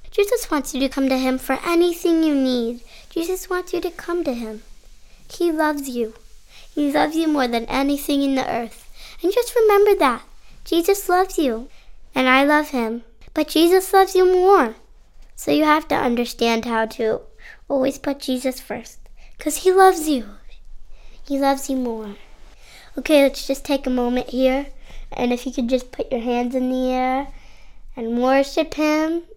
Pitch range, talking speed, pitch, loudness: 255-340 Hz, 175 wpm, 275 Hz, -20 LUFS